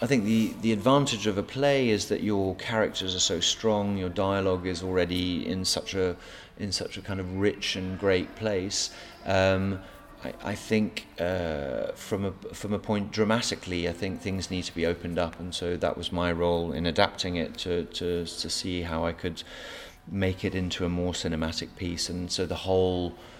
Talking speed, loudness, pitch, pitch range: 195 wpm, -28 LUFS, 95 Hz, 85-100 Hz